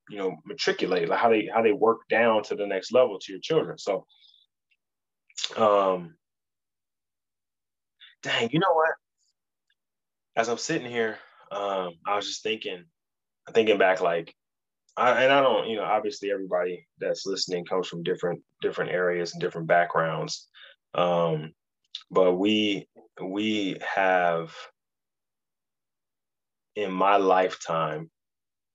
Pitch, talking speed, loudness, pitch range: 95 Hz, 125 wpm, -26 LUFS, 85-105 Hz